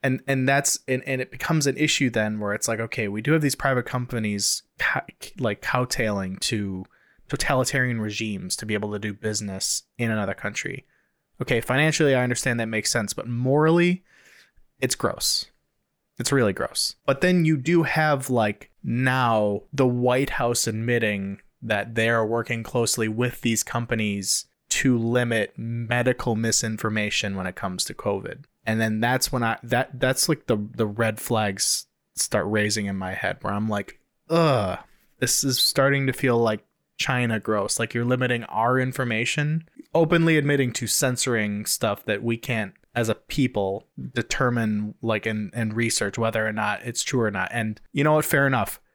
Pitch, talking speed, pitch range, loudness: 115 Hz, 170 wpm, 110-130 Hz, -24 LUFS